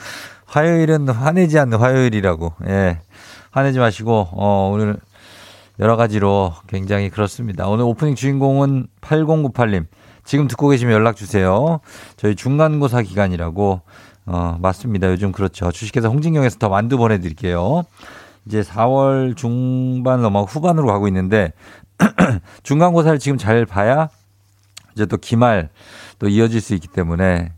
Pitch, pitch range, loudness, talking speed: 110 Hz, 100-130 Hz, -17 LUFS, 305 characters per minute